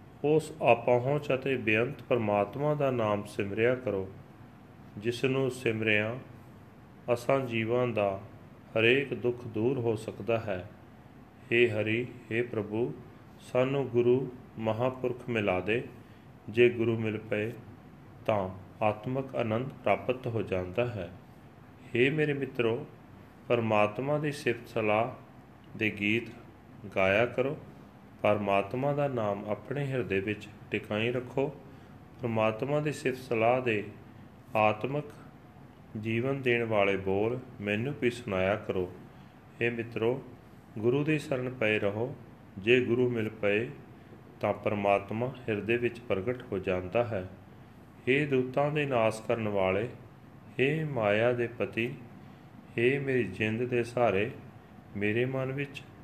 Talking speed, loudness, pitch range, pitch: 120 wpm, -30 LUFS, 105-125 Hz, 120 Hz